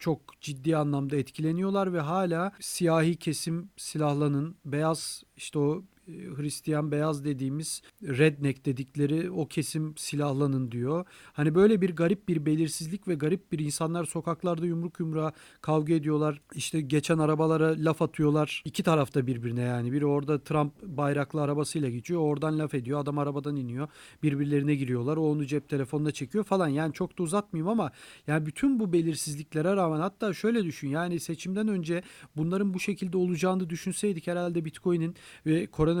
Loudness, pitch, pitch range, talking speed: -29 LUFS, 155 Hz, 145-175 Hz, 150 wpm